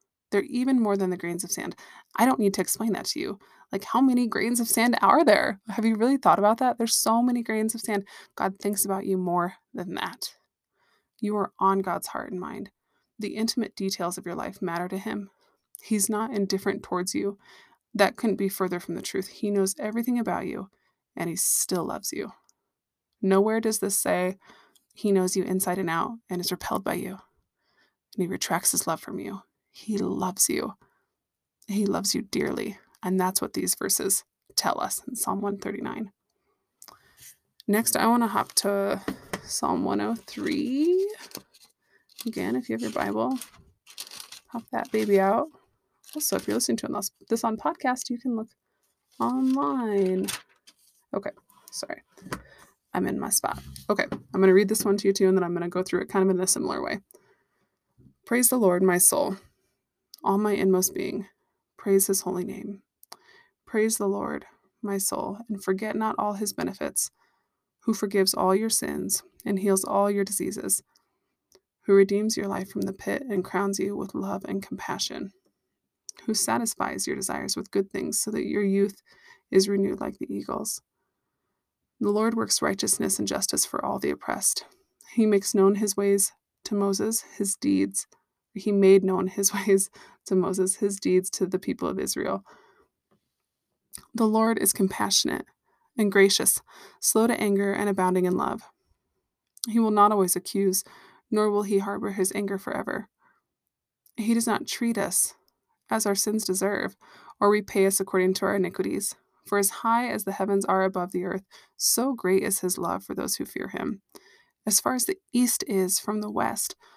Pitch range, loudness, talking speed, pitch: 190-225 Hz, -26 LUFS, 180 wpm, 200 Hz